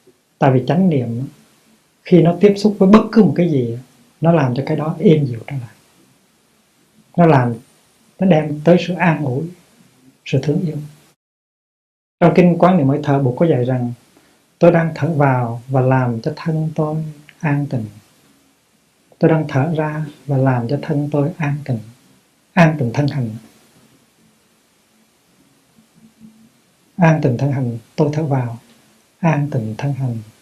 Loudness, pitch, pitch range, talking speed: -16 LUFS, 145 Hz, 130-165 Hz, 160 wpm